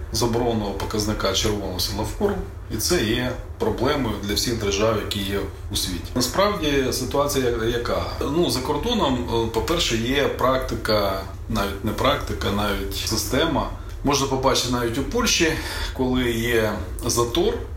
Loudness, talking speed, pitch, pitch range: -23 LUFS, 130 wpm, 110 Hz, 100-125 Hz